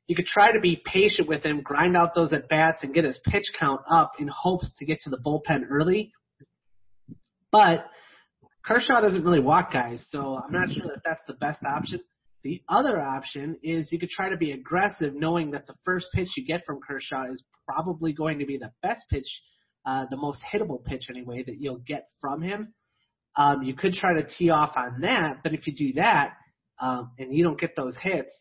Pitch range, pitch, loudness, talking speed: 135-175 Hz, 155 Hz, -25 LUFS, 215 wpm